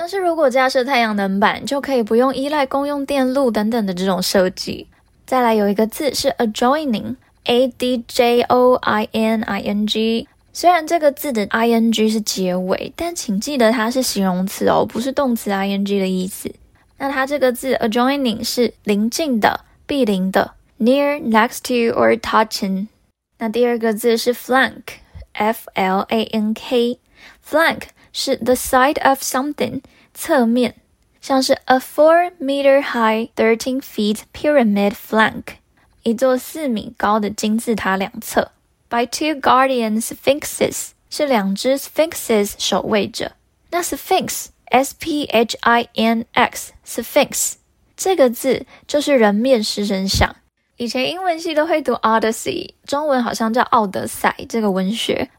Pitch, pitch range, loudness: 240 Hz, 220-270 Hz, -18 LUFS